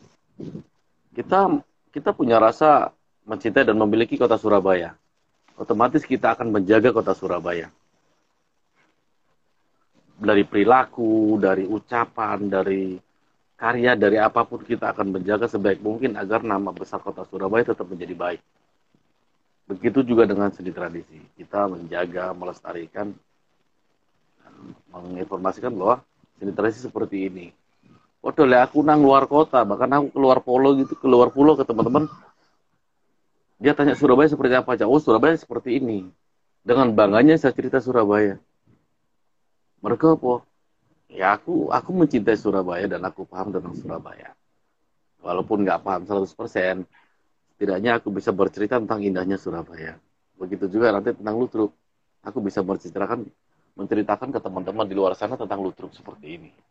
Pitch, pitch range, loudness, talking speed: 105 Hz, 95-125 Hz, -21 LUFS, 130 wpm